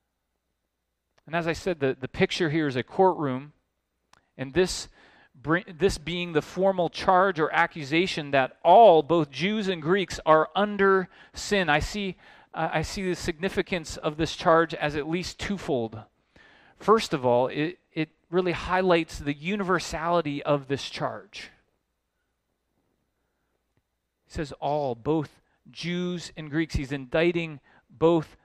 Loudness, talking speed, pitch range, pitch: -25 LUFS, 135 wpm, 145-185 Hz, 165 Hz